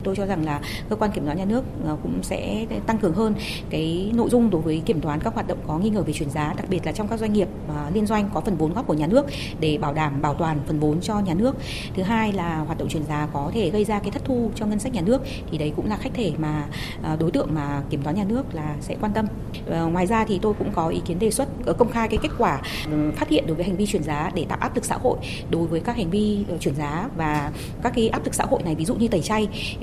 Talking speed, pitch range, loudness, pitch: 290 wpm, 150-215 Hz, -24 LUFS, 175 Hz